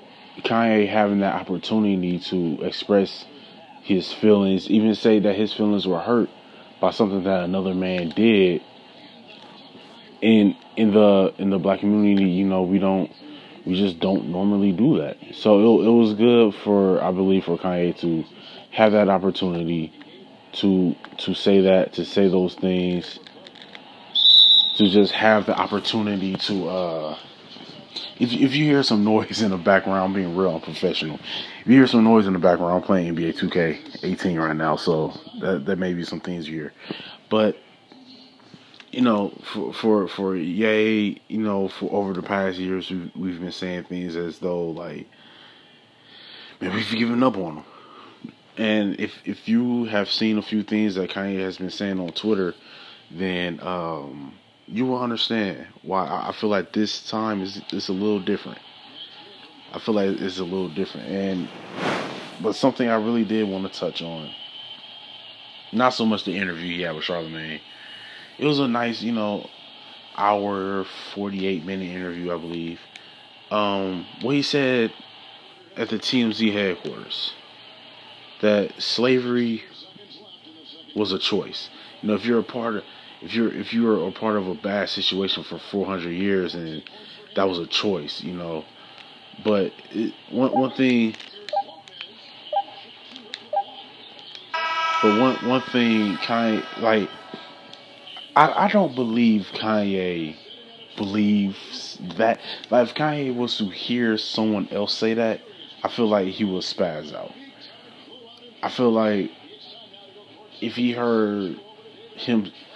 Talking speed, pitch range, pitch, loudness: 155 wpm, 95-110 Hz, 100 Hz, -22 LUFS